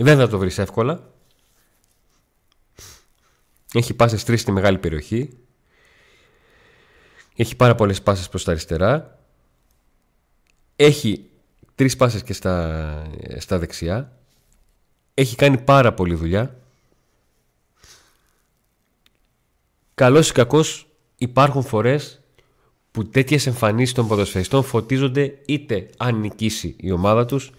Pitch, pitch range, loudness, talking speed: 115 Hz, 95-135 Hz, -19 LUFS, 130 wpm